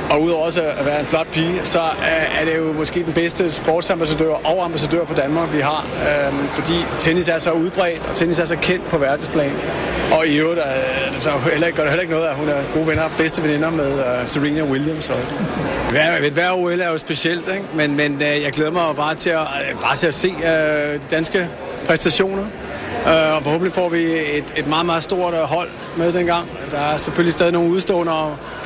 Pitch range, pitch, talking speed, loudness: 150-170 Hz, 160 Hz, 210 wpm, -18 LUFS